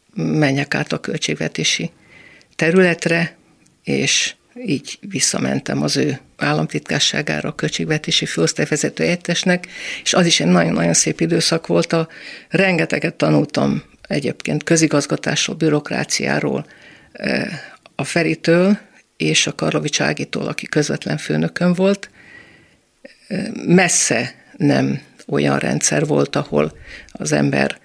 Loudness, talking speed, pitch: -18 LUFS, 100 wpm, 160 Hz